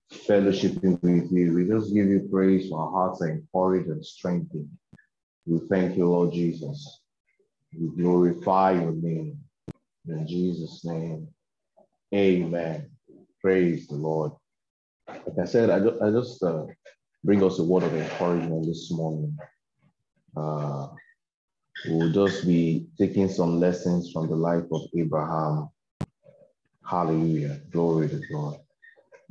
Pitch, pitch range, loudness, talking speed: 85 Hz, 80-95 Hz, -25 LUFS, 125 wpm